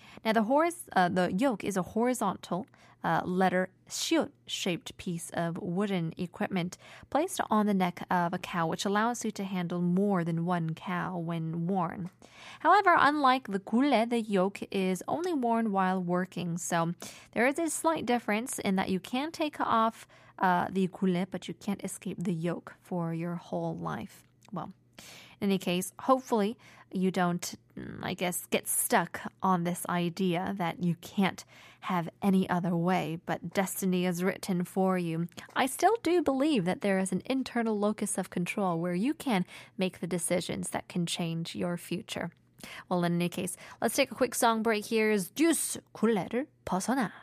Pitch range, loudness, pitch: 180-225 Hz, -30 LUFS, 190 Hz